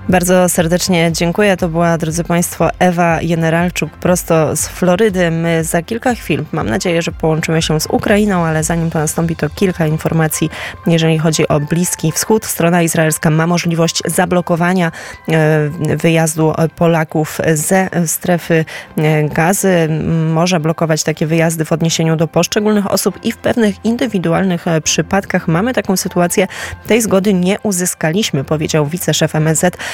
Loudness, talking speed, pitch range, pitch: -14 LUFS, 140 wpm, 160-180 Hz, 170 Hz